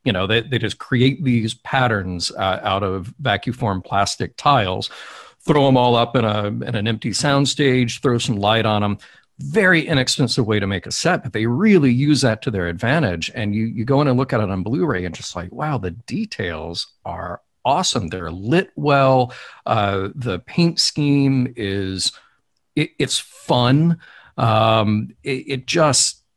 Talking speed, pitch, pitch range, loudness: 180 wpm, 120 Hz, 105-140 Hz, -19 LUFS